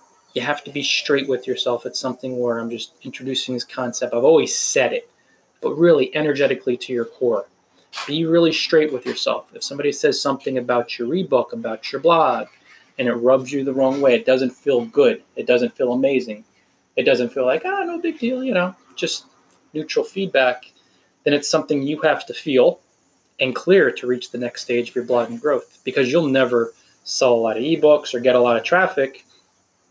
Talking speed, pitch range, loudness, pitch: 205 wpm, 125-160 Hz, -20 LUFS, 135 Hz